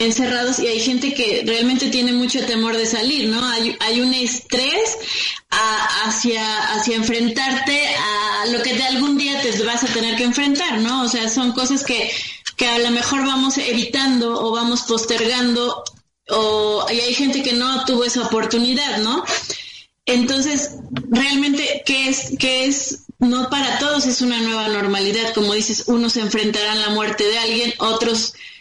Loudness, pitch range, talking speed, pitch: -18 LUFS, 225-260 Hz, 165 wpm, 240 Hz